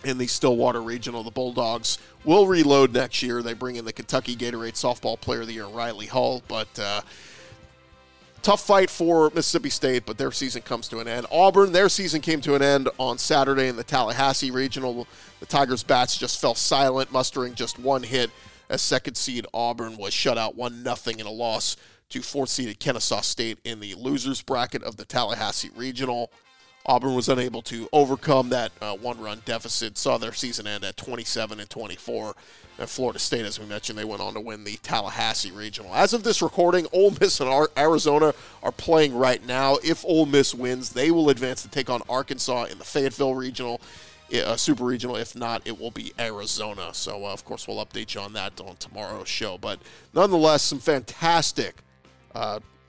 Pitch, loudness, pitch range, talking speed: 125 Hz, -24 LUFS, 115-140 Hz, 190 wpm